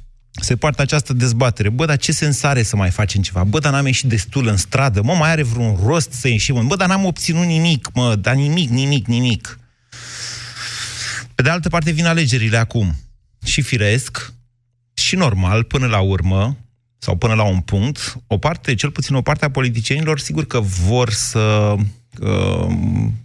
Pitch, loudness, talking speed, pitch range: 120 Hz, -17 LUFS, 180 wpm, 110-140 Hz